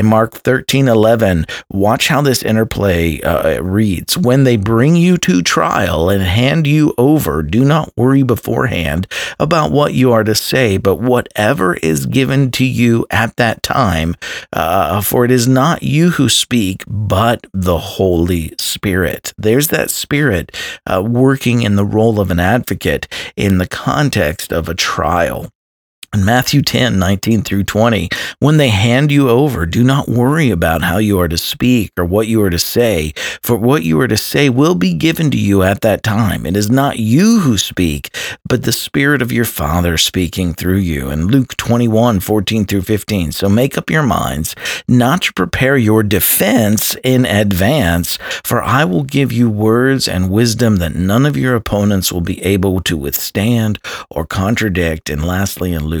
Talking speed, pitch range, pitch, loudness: 175 wpm, 95-125 Hz, 110 Hz, -13 LUFS